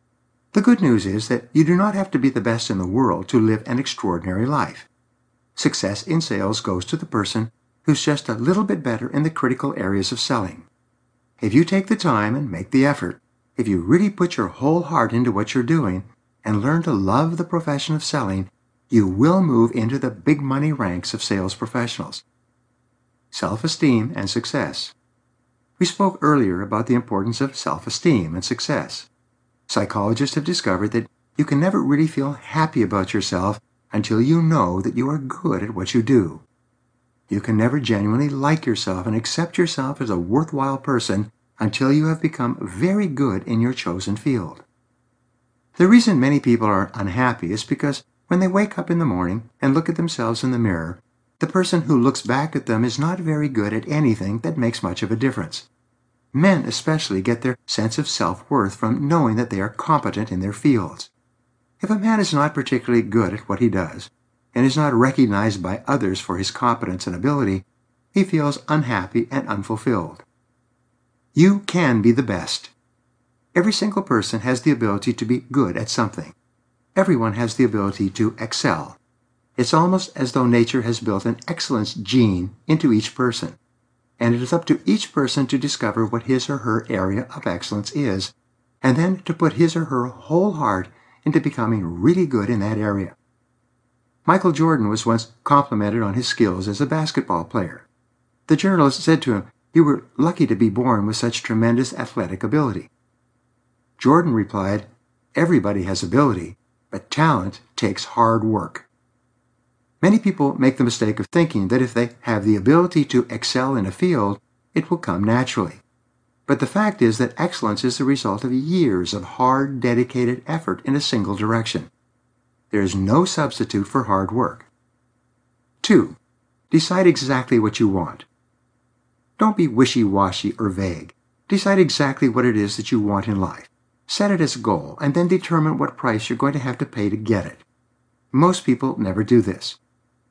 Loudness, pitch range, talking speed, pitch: -20 LUFS, 110-145 Hz, 180 wpm, 120 Hz